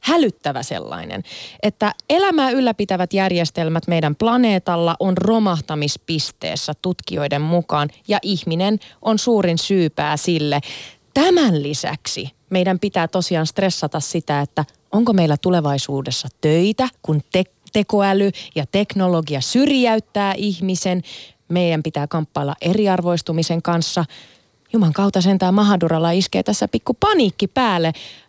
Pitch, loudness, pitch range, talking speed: 180 Hz, -19 LUFS, 155-205 Hz, 110 wpm